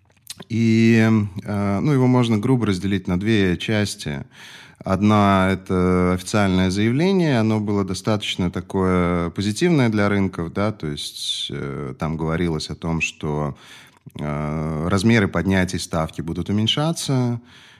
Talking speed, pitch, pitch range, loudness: 110 wpm, 100 Hz, 90-110 Hz, -20 LUFS